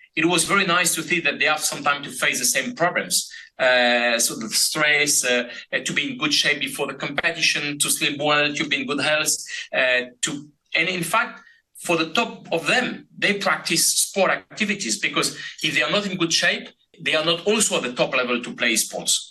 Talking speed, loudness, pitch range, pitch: 220 wpm, -20 LUFS, 145-175 Hz, 155 Hz